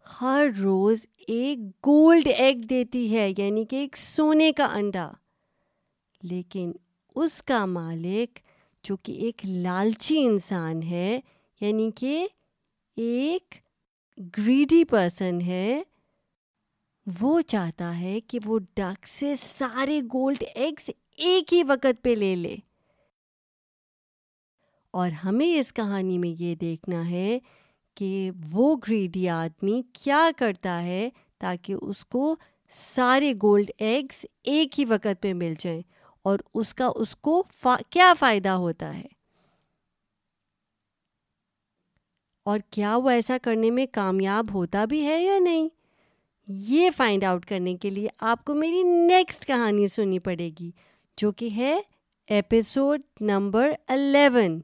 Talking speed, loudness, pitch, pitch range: 125 wpm, -24 LUFS, 225 Hz, 190-270 Hz